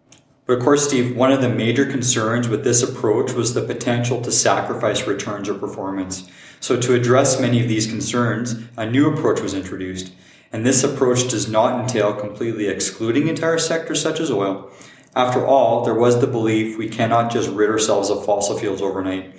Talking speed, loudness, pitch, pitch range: 185 wpm, -19 LUFS, 115 Hz, 105-125 Hz